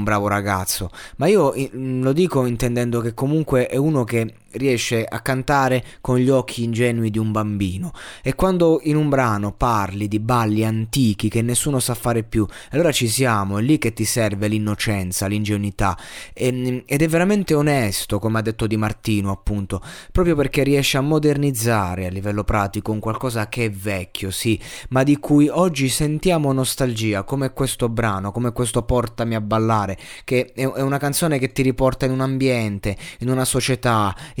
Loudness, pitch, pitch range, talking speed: -20 LUFS, 120 Hz, 105-135 Hz, 175 wpm